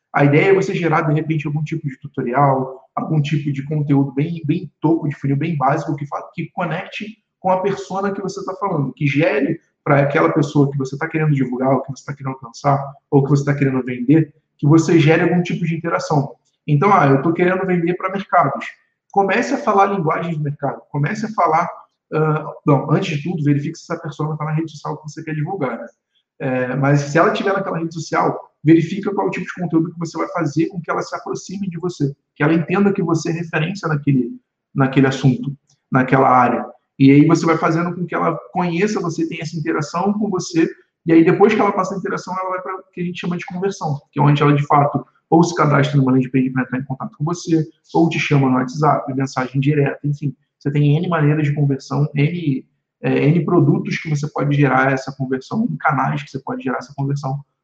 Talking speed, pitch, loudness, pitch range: 225 wpm, 155 Hz, -18 LUFS, 140-175 Hz